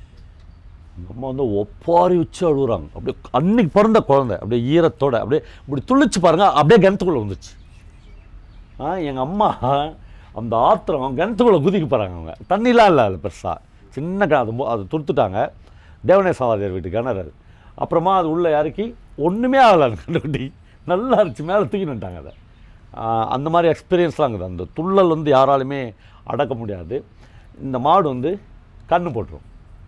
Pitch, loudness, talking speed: 135 Hz, -18 LUFS, 135 wpm